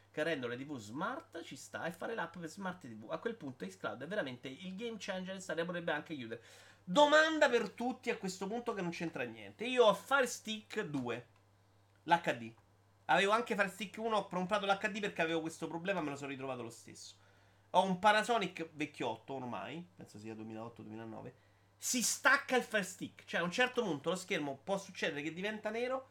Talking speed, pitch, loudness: 195 wpm, 170 Hz, -36 LUFS